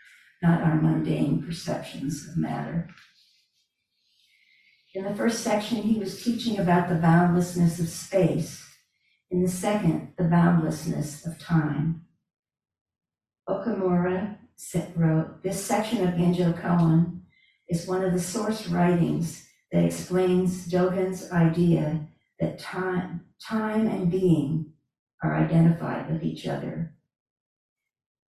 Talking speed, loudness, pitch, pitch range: 110 wpm, -25 LUFS, 175 Hz, 160-190 Hz